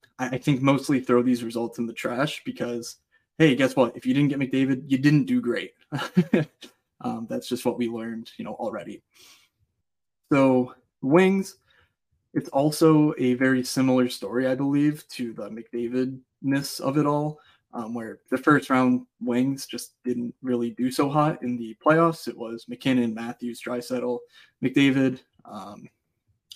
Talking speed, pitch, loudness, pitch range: 160 wpm, 130 Hz, -24 LUFS, 120-145 Hz